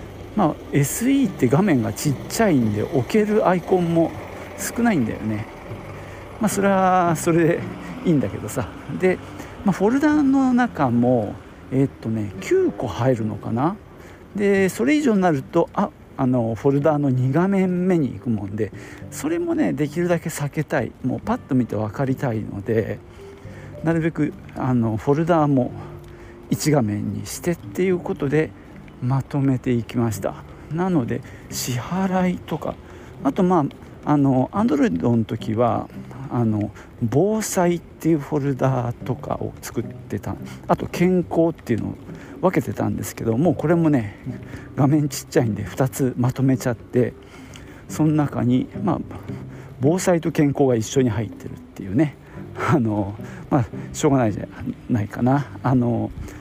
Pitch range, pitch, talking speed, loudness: 115-170 Hz, 135 Hz, 285 characters per minute, -22 LUFS